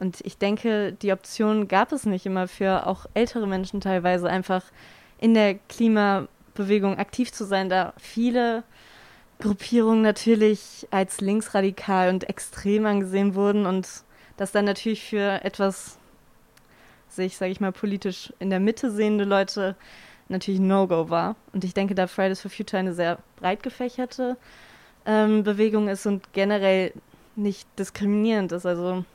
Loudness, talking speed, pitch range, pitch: -24 LUFS, 145 wpm, 190-215 Hz, 200 Hz